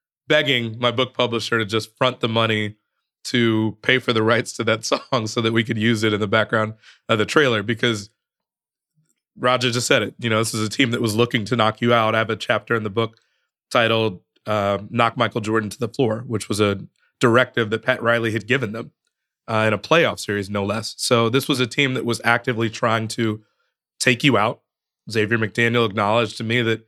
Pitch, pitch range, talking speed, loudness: 115 Hz, 110-120 Hz, 220 wpm, -20 LUFS